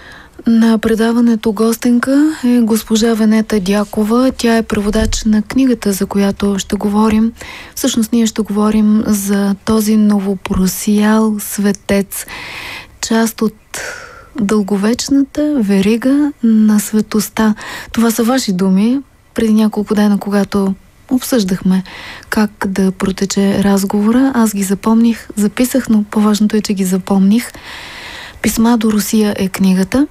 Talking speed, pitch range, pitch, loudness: 115 wpm, 205-230 Hz, 215 Hz, -13 LUFS